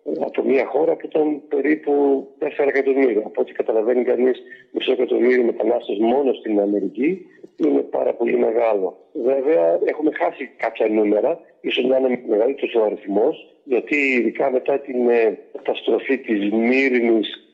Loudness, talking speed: -20 LUFS, 135 wpm